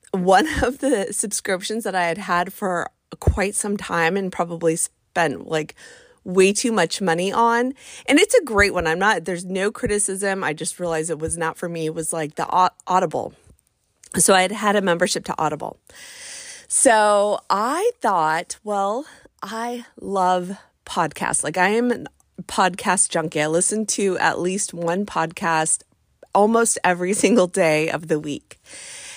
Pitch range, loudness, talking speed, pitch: 170-205 Hz, -20 LUFS, 165 wpm, 185 Hz